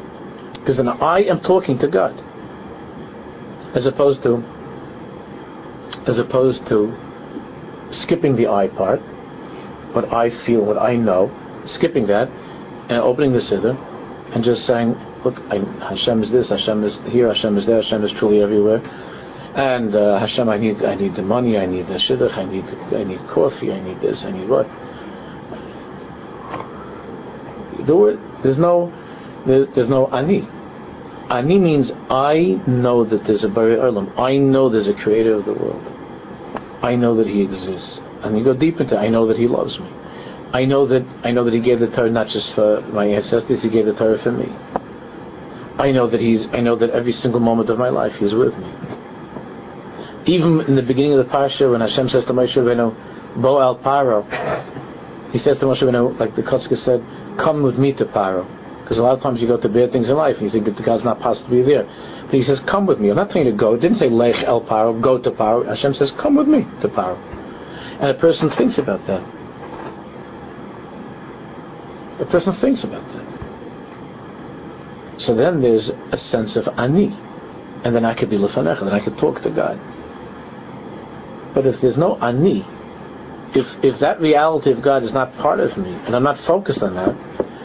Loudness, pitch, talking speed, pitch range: -17 LUFS, 120 Hz, 190 wpm, 110-135 Hz